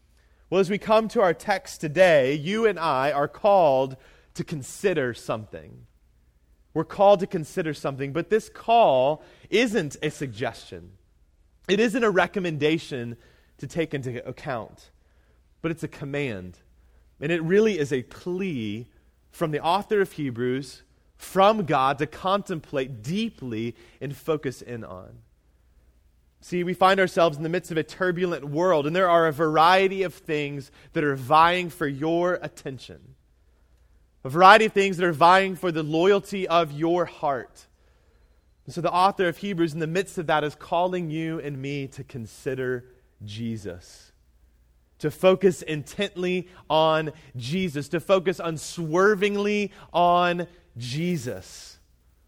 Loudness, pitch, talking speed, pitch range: -24 LUFS, 155 Hz, 145 wpm, 115-180 Hz